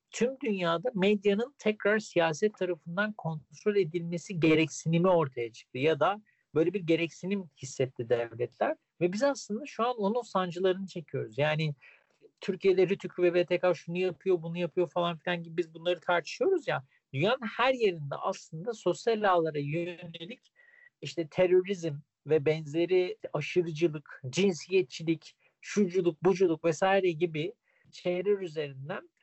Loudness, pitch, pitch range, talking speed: -30 LUFS, 180 Hz, 165-205 Hz, 125 wpm